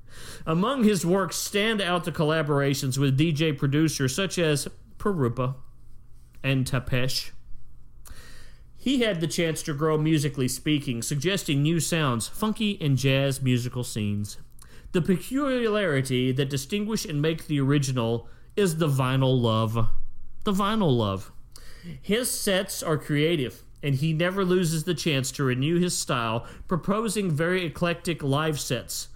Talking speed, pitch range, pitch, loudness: 135 wpm, 130-180 Hz, 150 Hz, -25 LUFS